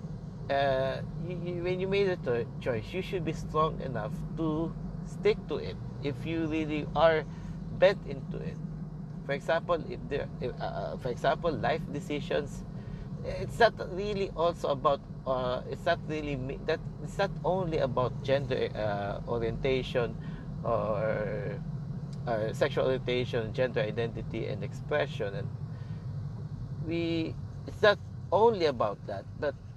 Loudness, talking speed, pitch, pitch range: -32 LUFS, 135 wpm, 155 Hz, 135-165 Hz